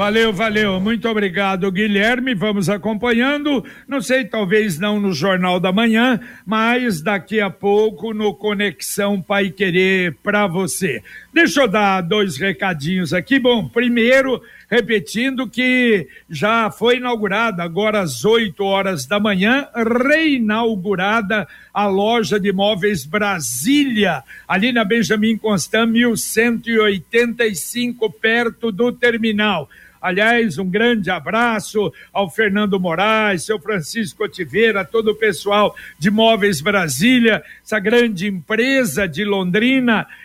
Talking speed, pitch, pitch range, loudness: 120 wpm, 215 Hz, 200-230 Hz, -17 LUFS